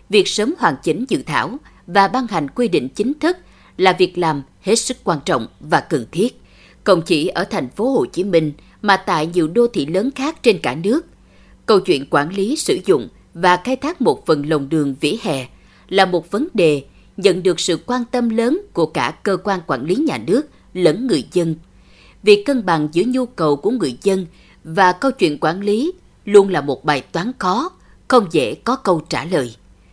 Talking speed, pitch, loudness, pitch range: 205 wpm, 190 Hz, -18 LUFS, 160-250 Hz